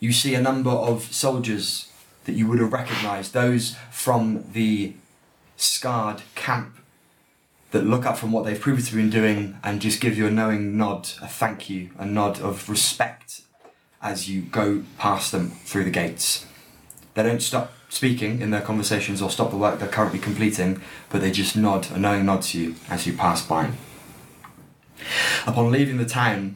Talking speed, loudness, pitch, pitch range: 175 wpm, -23 LUFS, 105 Hz, 100-115 Hz